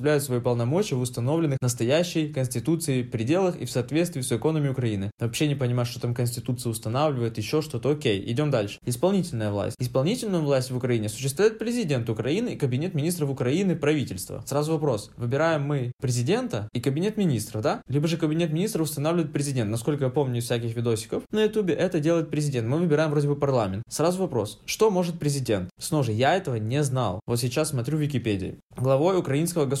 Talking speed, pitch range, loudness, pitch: 180 wpm, 120-160 Hz, -26 LUFS, 140 Hz